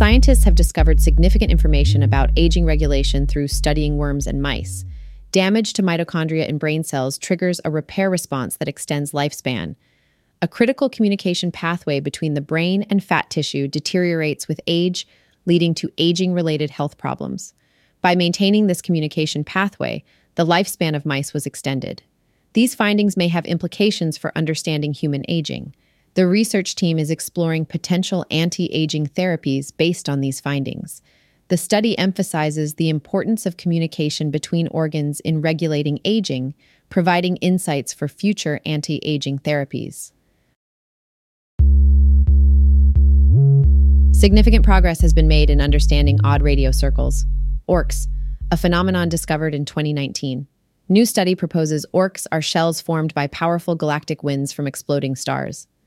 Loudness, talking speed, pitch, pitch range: -19 LUFS, 135 wpm, 155 Hz, 140-175 Hz